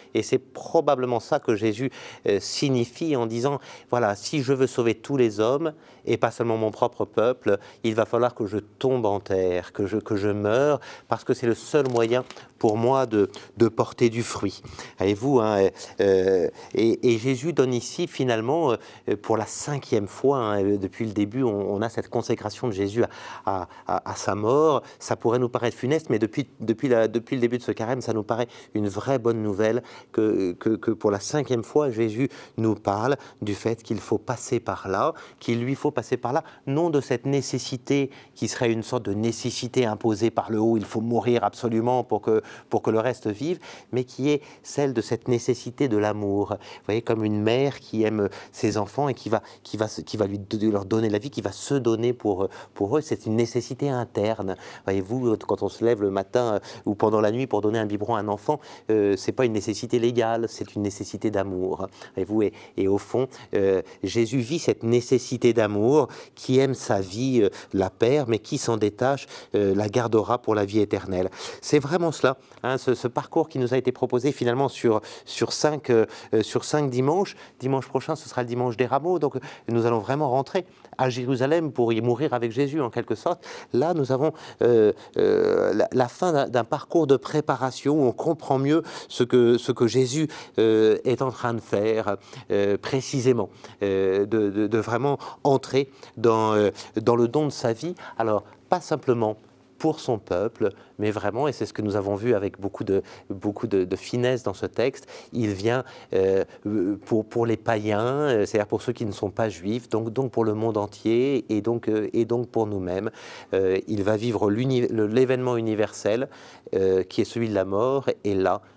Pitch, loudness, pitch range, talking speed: 120 Hz, -25 LUFS, 105-130 Hz, 205 wpm